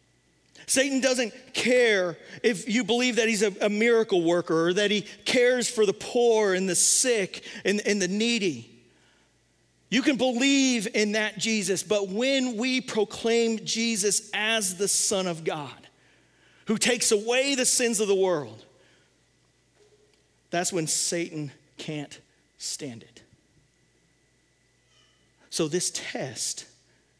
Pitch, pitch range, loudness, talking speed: 215 Hz, 180-235 Hz, -24 LUFS, 125 wpm